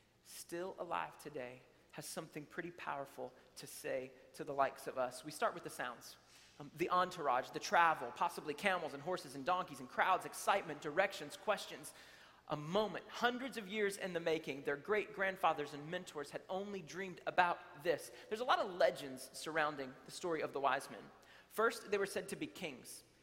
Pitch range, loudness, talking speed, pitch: 145-195 Hz, -40 LUFS, 185 wpm, 170 Hz